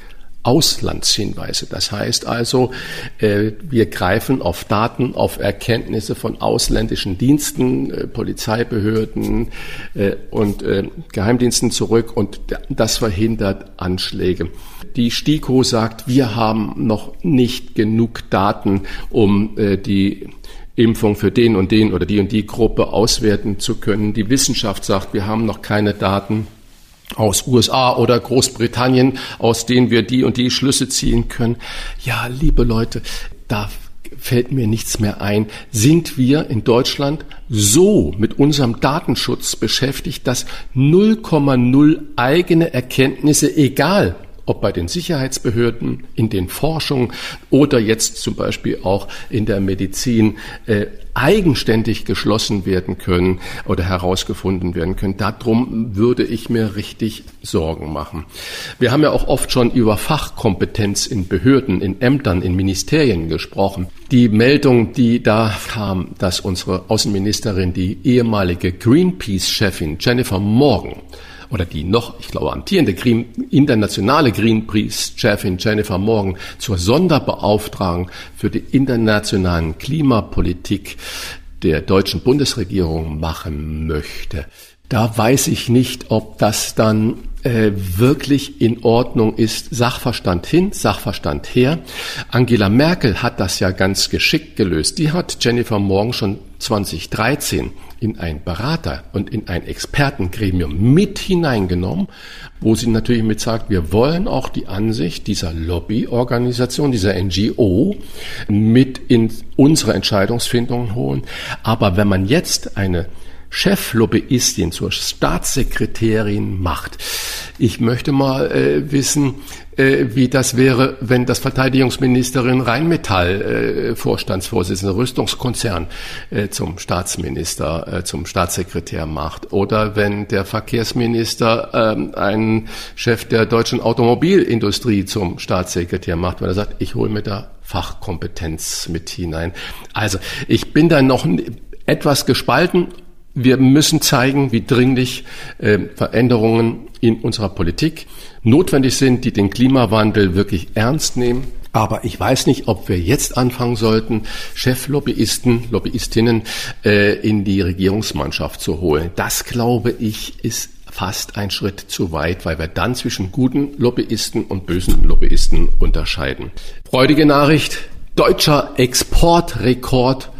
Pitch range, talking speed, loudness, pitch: 95-125 Hz, 125 wpm, -17 LUFS, 110 Hz